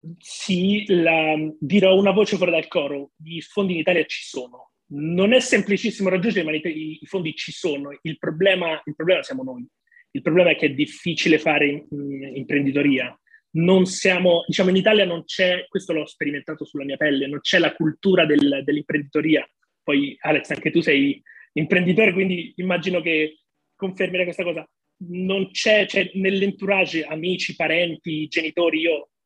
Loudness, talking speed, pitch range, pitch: -21 LUFS, 160 wpm, 155-190 Hz, 170 Hz